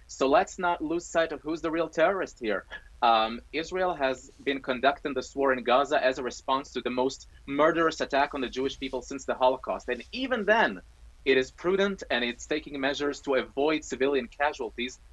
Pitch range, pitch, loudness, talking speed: 130-160 Hz, 140 Hz, -28 LUFS, 195 wpm